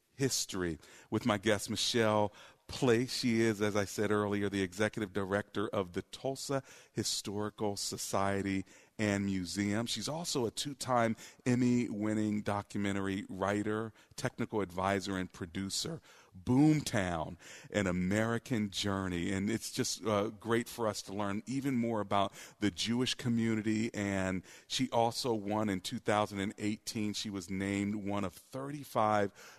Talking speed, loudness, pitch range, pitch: 135 wpm, -34 LUFS, 100-115 Hz, 105 Hz